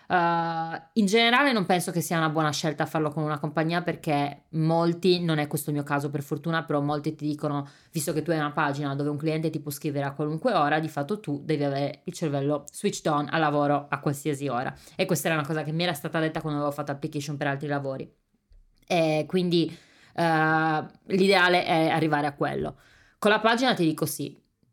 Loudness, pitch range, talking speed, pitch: -26 LUFS, 145-170 Hz, 215 wpm, 155 Hz